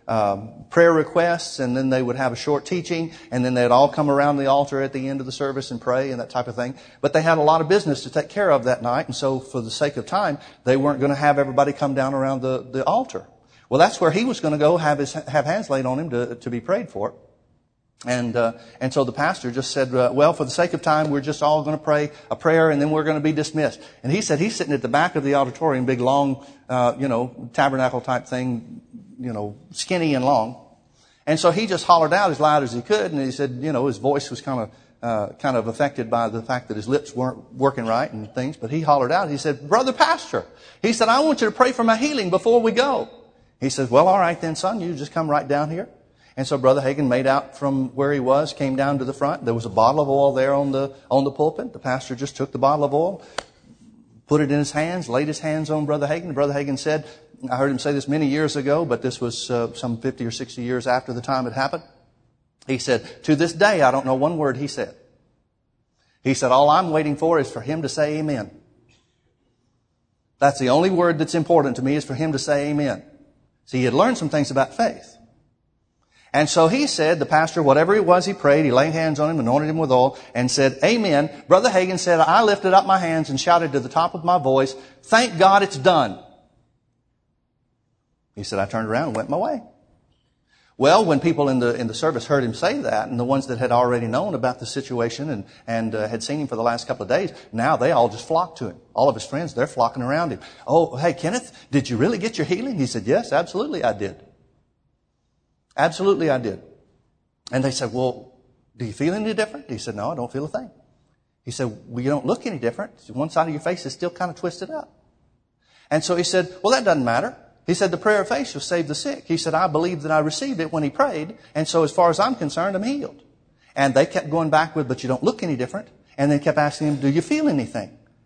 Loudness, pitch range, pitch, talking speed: -21 LUFS, 130-160 Hz, 140 Hz, 255 wpm